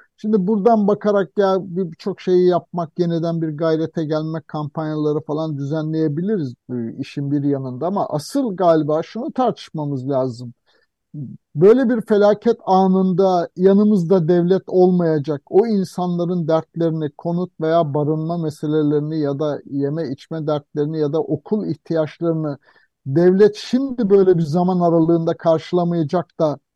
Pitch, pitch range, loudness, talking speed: 165 Hz, 155-190 Hz, -19 LUFS, 125 wpm